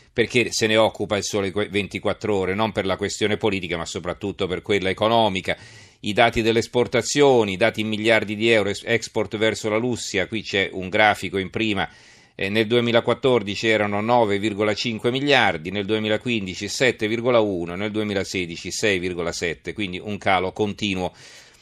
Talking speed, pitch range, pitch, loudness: 145 wpm, 100-115 Hz, 105 Hz, -22 LUFS